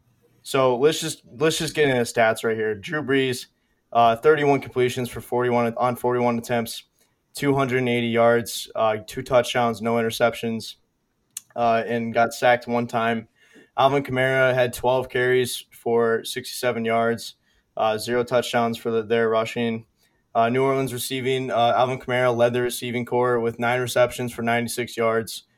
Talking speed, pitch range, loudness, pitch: 160 wpm, 115-125 Hz, -22 LUFS, 120 Hz